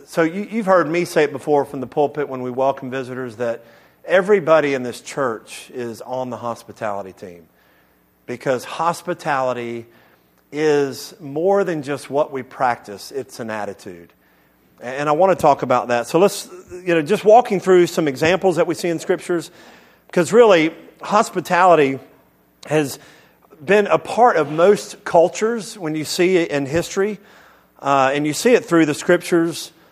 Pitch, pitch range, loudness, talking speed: 155 Hz, 130-180 Hz, -18 LUFS, 165 wpm